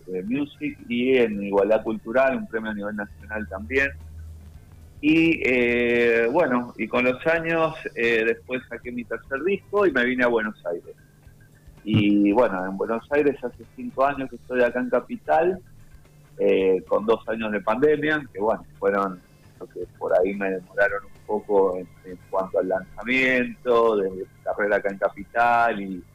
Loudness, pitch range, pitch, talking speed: -23 LUFS, 100-135 Hz, 120 Hz, 170 wpm